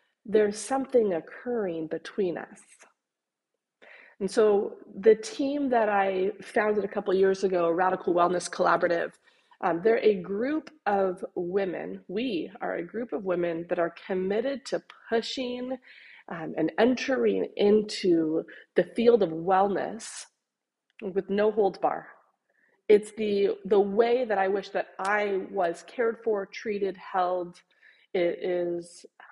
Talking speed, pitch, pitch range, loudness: 130 wpm, 200 Hz, 185-230 Hz, -27 LUFS